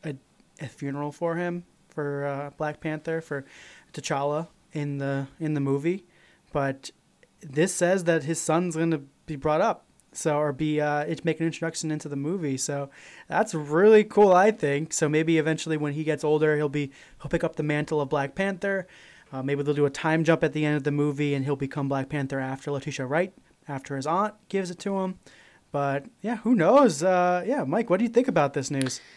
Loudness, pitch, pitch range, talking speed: -26 LUFS, 155 Hz, 145-175 Hz, 210 wpm